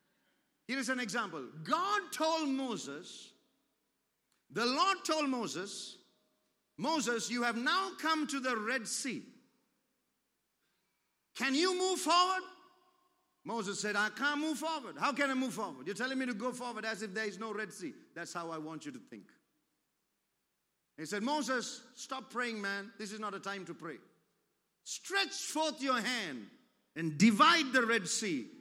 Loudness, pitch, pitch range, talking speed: -34 LUFS, 255 Hz, 220-305 Hz, 160 wpm